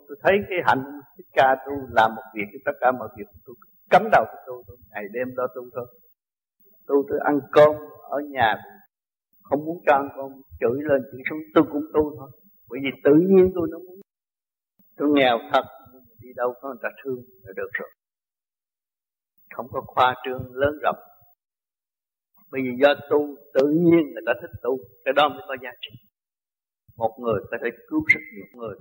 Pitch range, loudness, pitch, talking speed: 125-155 Hz, -22 LUFS, 140 Hz, 200 wpm